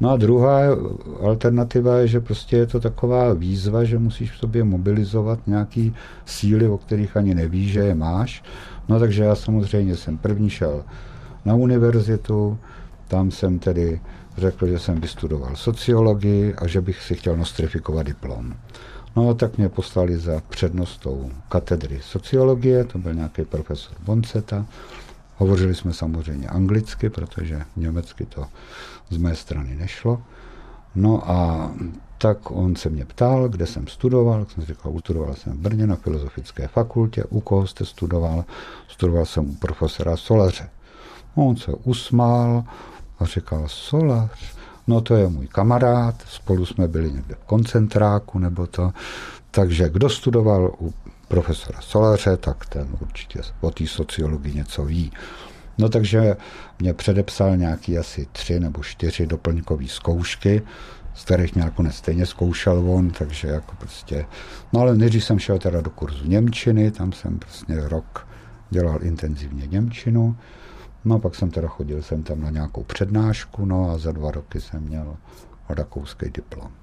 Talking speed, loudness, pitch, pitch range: 150 wpm, -21 LUFS, 95 Hz, 80-110 Hz